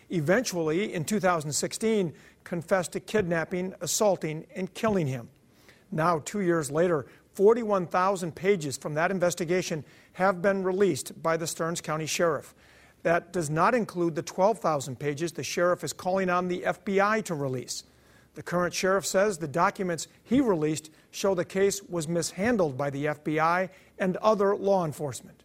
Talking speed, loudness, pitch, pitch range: 150 wpm, -27 LUFS, 175 Hz, 160-195 Hz